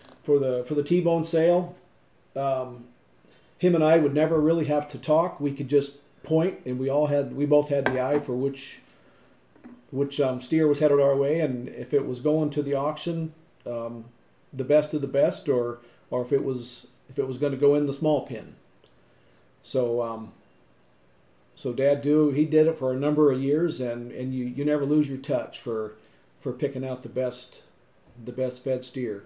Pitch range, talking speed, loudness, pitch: 125-150 Hz, 200 wpm, -25 LUFS, 140 Hz